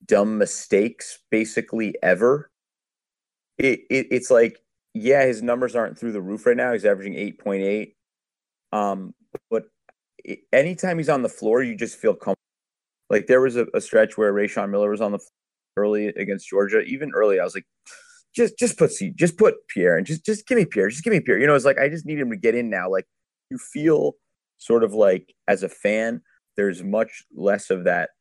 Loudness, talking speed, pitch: -22 LUFS, 205 wpm, 130 Hz